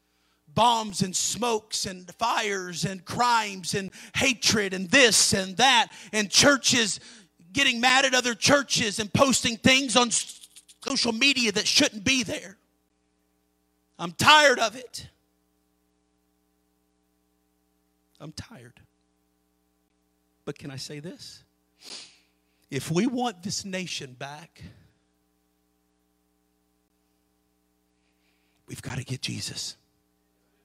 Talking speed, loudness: 100 wpm, -22 LUFS